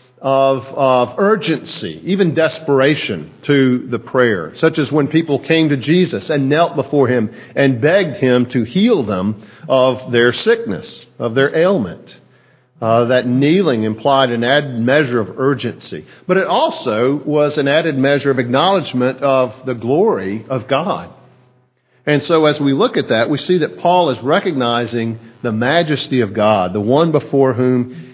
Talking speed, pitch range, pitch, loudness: 160 wpm, 125-150 Hz, 135 Hz, -15 LUFS